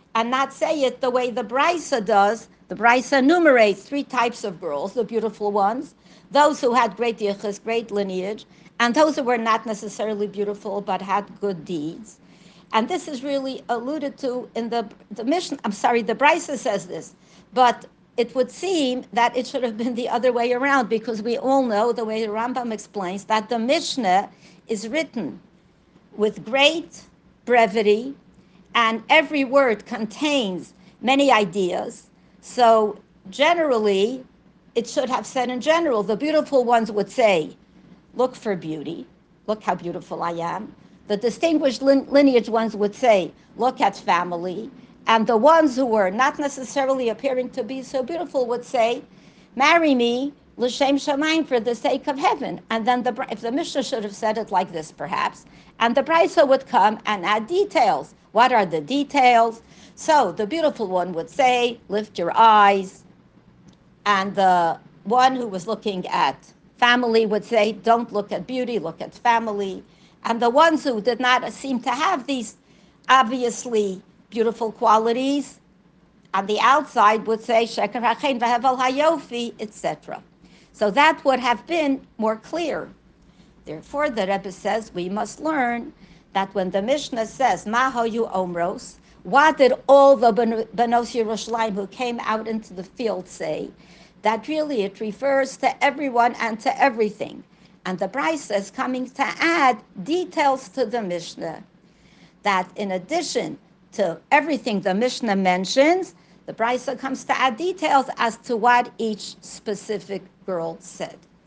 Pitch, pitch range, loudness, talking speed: 235 Hz, 205-265 Hz, -21 LUFS, 155 wpm